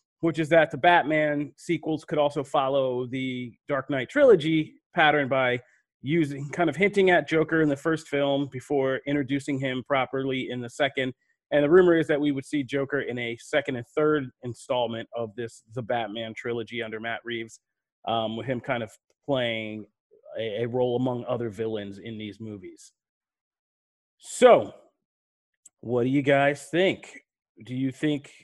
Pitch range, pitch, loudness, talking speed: 120-150 Hz, 135 Hz, -25 LUFS, 165 wpm